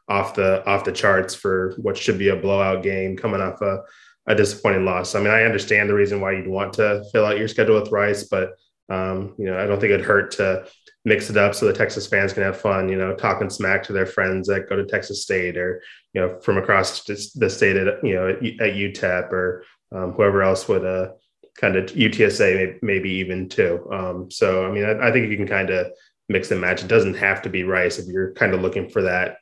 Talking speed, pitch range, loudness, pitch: 240 wpm, 95-100 Hz, -20 LUFS, 95 Hz